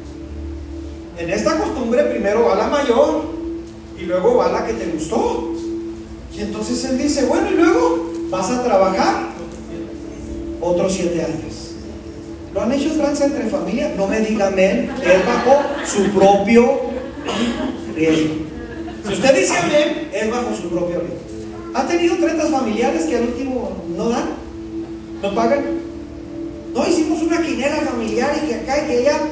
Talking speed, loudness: 150 wpm, -18 LUFS